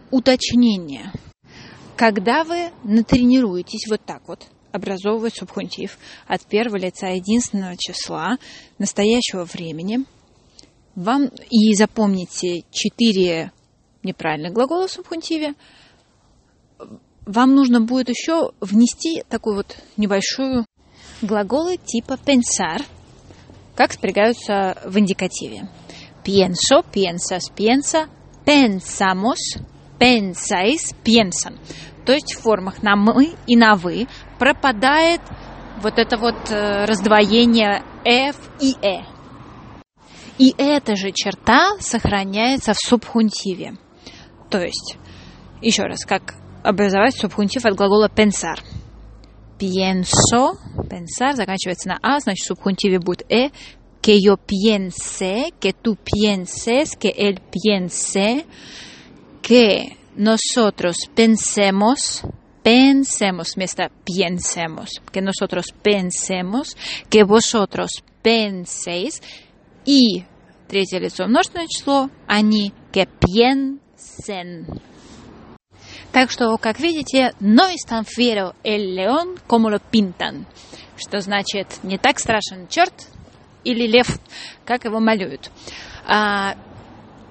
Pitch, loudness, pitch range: 215 Hz, -18 LUFS, 195-245 Hz